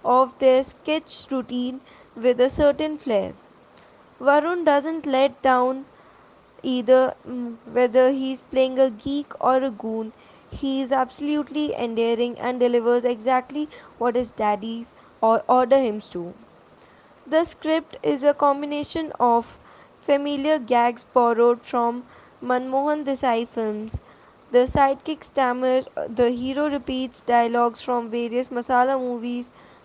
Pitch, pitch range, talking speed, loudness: 255 Hz, 240-280 Hz, 120 wpm, -22 LUFS